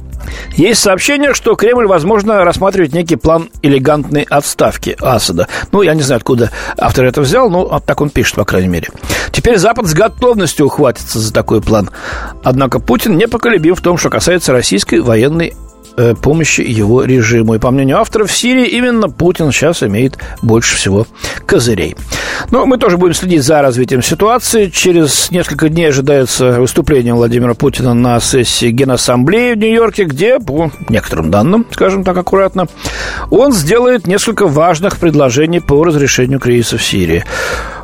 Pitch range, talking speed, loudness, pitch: 120-185 Hz, 155 wpm, -10 LUFS, 145 Hz